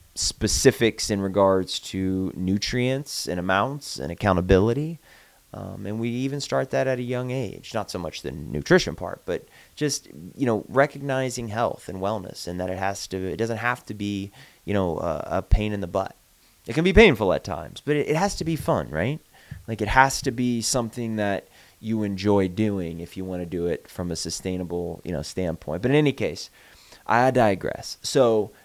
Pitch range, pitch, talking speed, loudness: 95-130 Hz, 105 Hz, 195 wpm, -24 LUFS